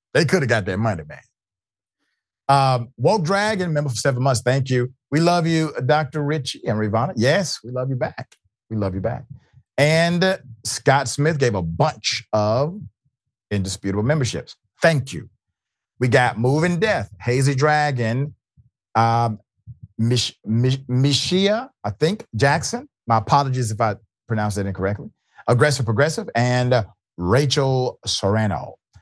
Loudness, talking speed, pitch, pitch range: -20 LUFS, 145 wpm, 125 Hz, 110-145 Hz